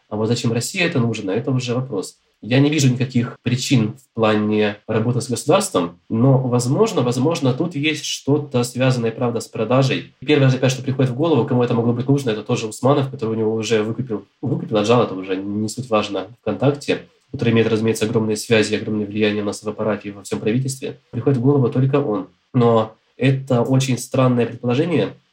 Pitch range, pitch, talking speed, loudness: 110-135 Hz, 120 Hz, 190 wpm, -19 LUFS